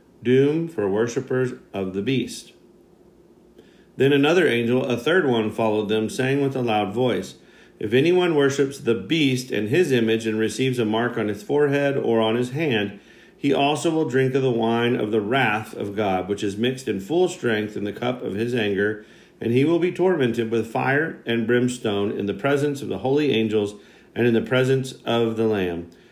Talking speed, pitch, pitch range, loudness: 195 wpm, 120 Hz, 110-140 Hz, -22 LUFS